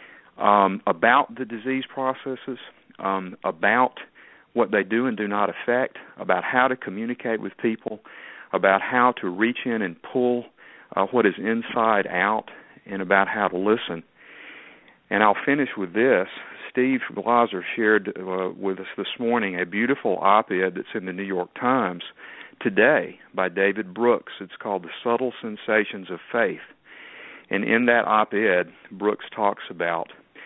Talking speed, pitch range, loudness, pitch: 155 wpm, 95-125 Hz, -23 LUFS, 110 Hz